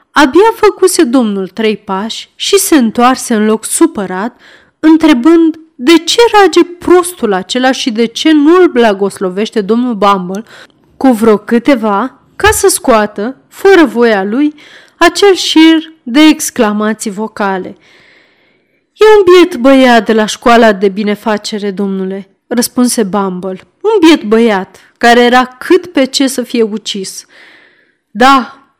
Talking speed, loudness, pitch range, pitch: 130 wpm, -9 LUFS, 215-320 Hz, 250 Hz